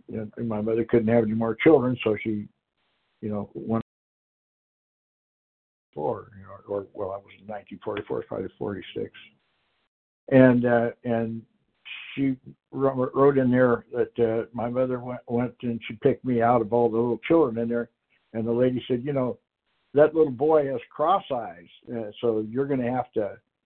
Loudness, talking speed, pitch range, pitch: -25 LUFS, 180 wpm, 115-125 Hz, 120 Hz